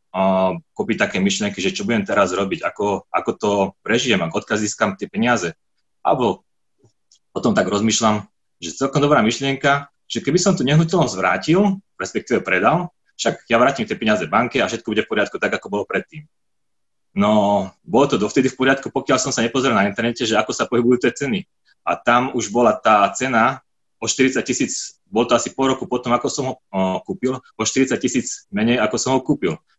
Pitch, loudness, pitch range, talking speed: 125 Hz, -19 LUFS, 105-135 Hz, 185 wpm